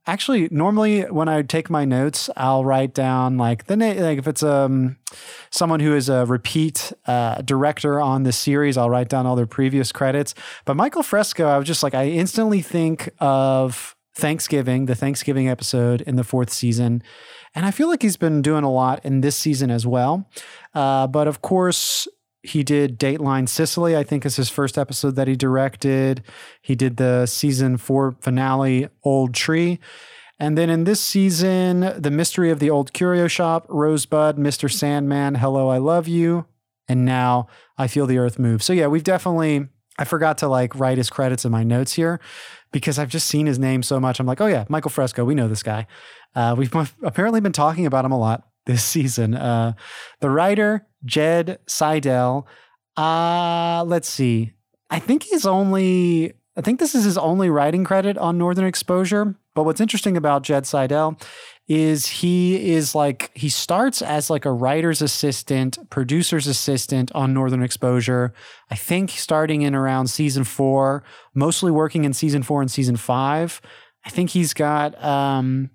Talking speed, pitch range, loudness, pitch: 180 wpm, 130-165 Hz, -20 LUFS, 145 Hz